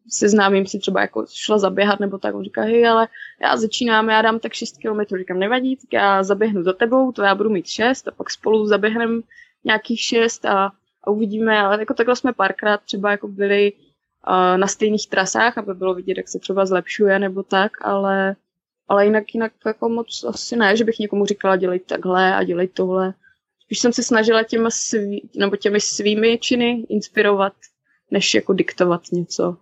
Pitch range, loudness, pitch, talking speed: 195-225 Hz, -19 LUFS, 210 Hz, 190 wpm